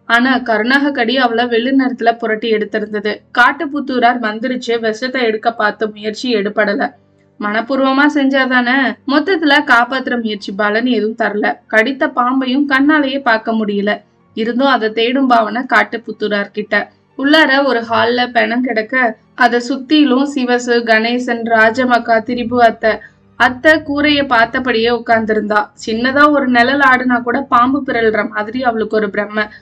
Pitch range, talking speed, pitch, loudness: 220-260 Hz, 115 wpm, 240 Hz, -13 LUFS